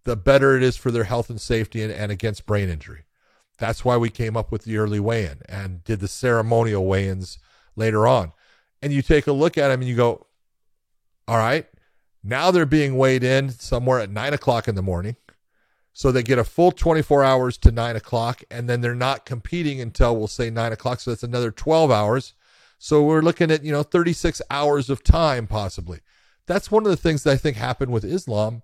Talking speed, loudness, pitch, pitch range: 215 wpm, -21 LUFS, 120 Hz, 110-140 Hz